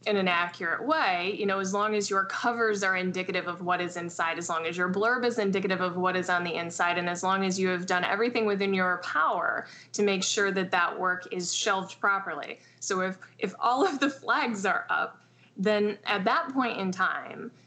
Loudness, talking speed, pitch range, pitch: -28 LUFS, 220 wpm, 180-210 Hz, 190 Hz